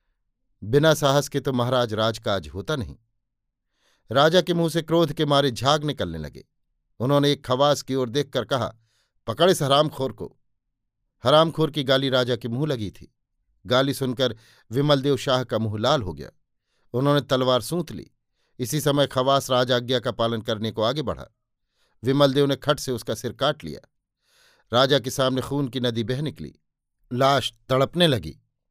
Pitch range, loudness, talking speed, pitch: 115-145 Hz, -23 LUFS, 165 wpm, 130 Hz